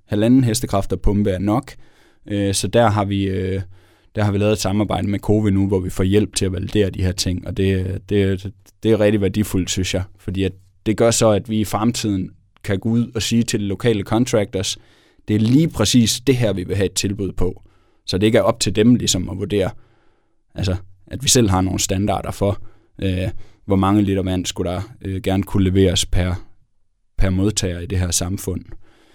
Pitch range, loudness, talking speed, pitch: 95-110 Hz, -19 LUFS, 210 wpm, 100 Hz